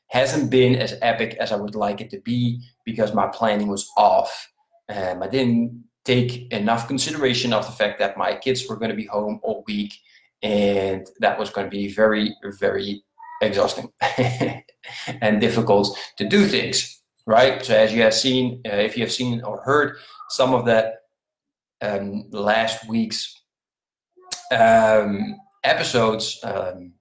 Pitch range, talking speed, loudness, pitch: 105-130 Hz, 160 wpm, -21 LUFS, 115 Hz